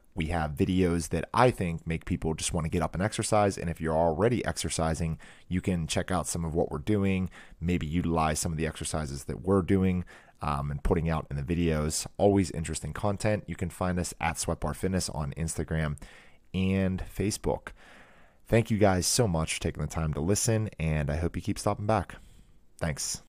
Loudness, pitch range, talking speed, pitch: -29 LUFS, 80-95 Hz, 200 wpm, 85 Hz